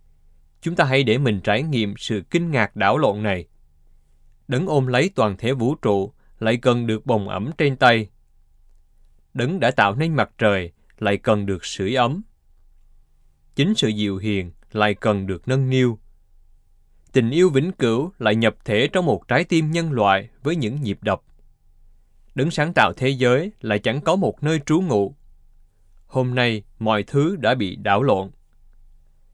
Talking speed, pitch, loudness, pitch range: 170 wpm, 110 Hz, -21 LUFS, 95-130 Hz